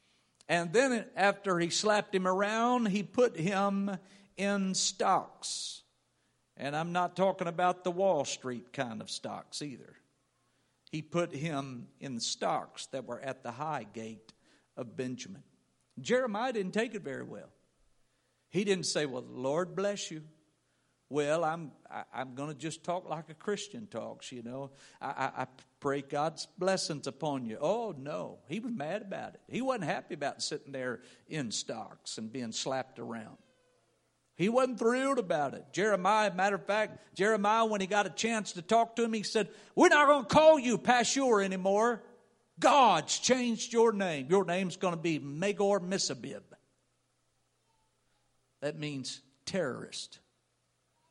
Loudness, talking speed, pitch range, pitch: -32 LUFS, 155 wpm, 140-210 Hz, 180 Hz